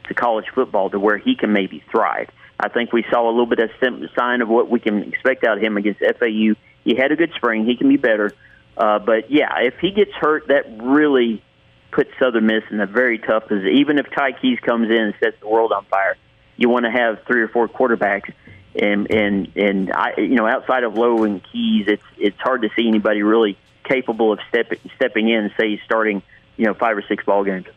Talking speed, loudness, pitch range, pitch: 230 wpm, -18 LUFS, 105-125 Hz, 115 Hz